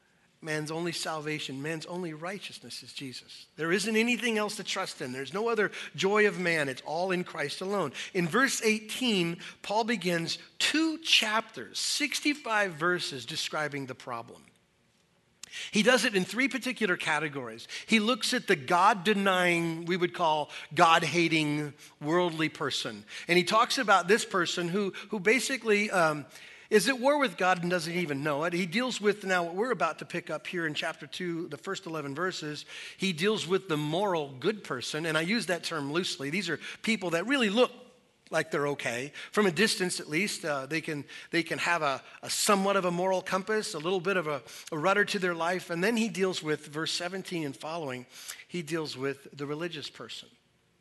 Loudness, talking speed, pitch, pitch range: -29 LUFS, 190 wpm, 175 Hz, 155-205 Hz